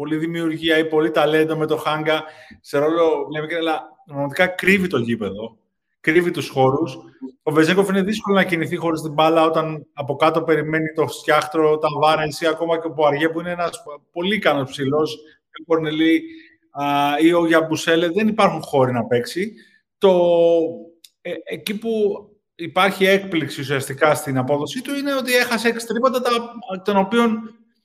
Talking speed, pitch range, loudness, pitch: 160 wpm, 155-195 Hz, -19 LUFS, 165 Hz